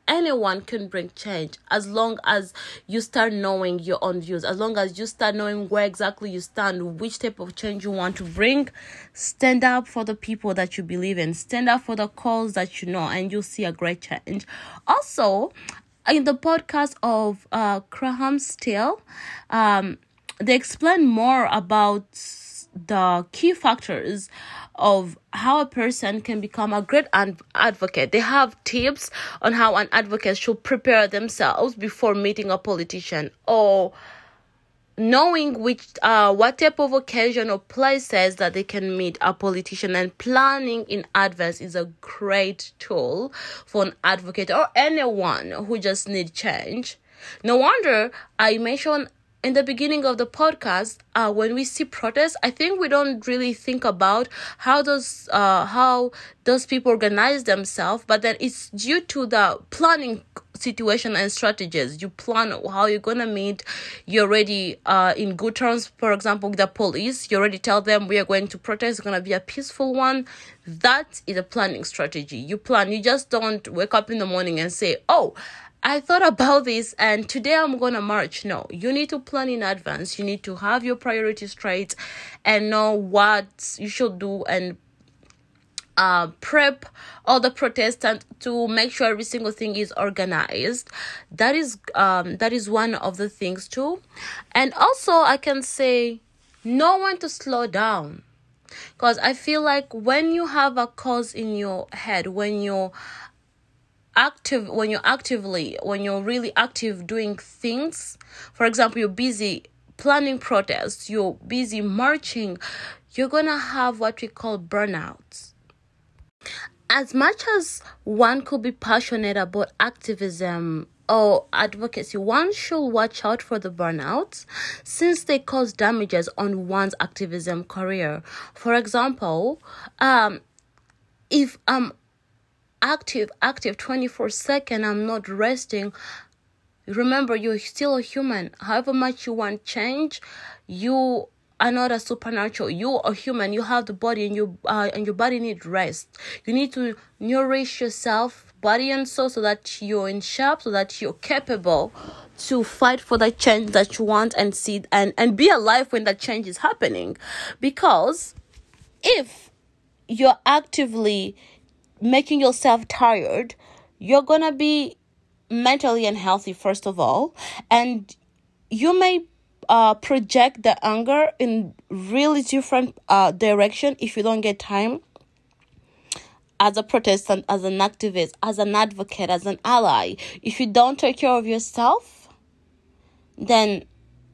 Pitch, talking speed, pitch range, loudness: 225 Hz, 155 wpm, 200-255 Hz, -22 LUFS